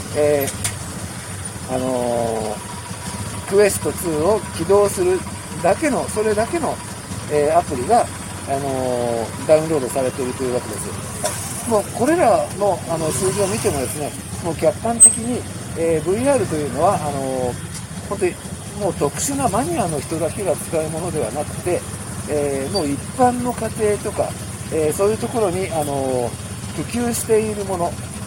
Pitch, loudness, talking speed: 135 Hz, -20 LUFS, 300 characters per minute